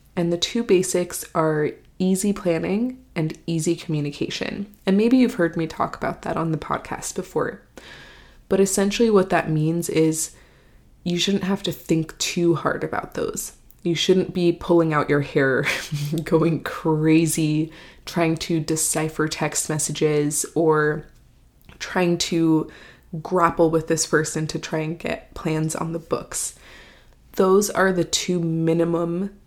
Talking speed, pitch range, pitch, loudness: 145 wpm, 160-185 Hz, 165 Hz, -22 LUFS